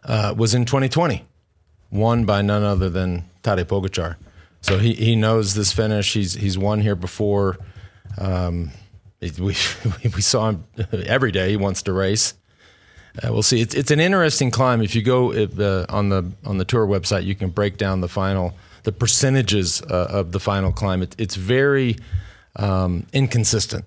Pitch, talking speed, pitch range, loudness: 100 Hz, 175 wpm, 95-115 Hz, -20 LUFS